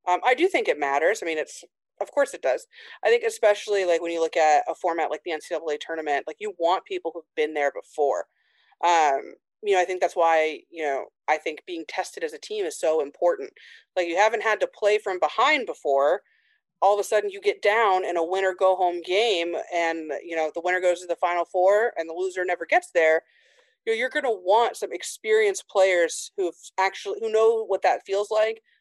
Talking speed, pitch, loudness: 230 wpm, 195 Hz, -24 LUFS